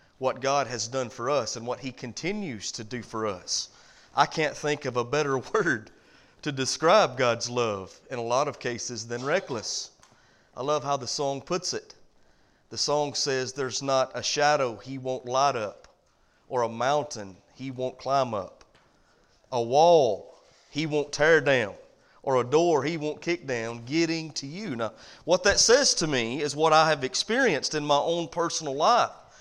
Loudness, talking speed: -26 LUFS, 180 wpm